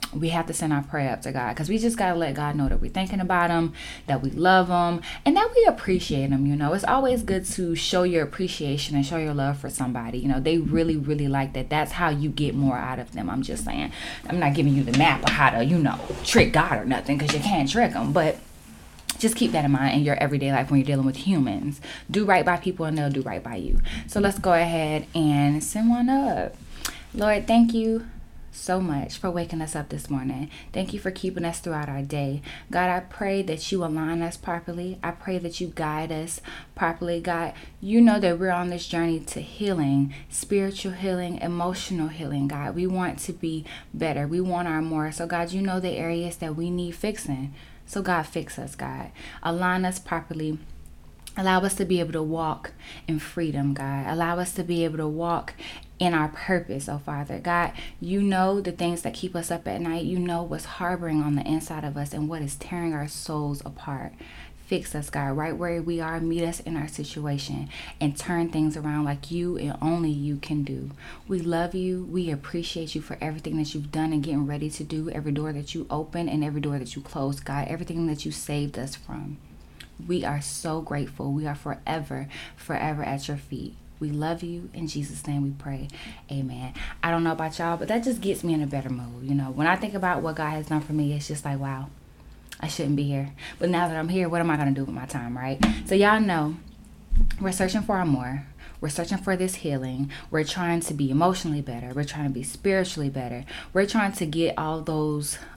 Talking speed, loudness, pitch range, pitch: 225 wpm, -26 LUFS, 145-175 Hz, 160 Hz